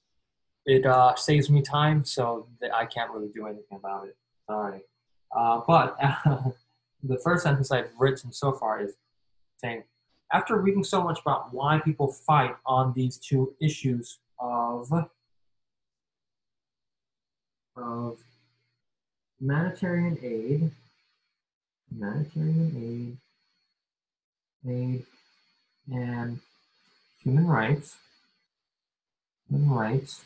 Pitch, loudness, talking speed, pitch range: 130 Hz, -27 LUFS, 105 wpm, 120-145 Hz